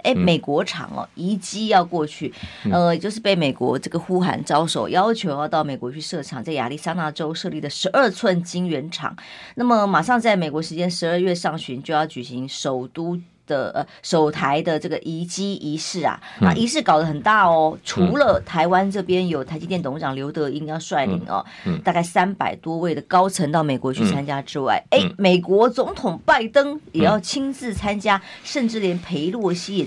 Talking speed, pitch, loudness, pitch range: 285 characters per minute, 175 Hz, -21 LUFS, 155-195 Hz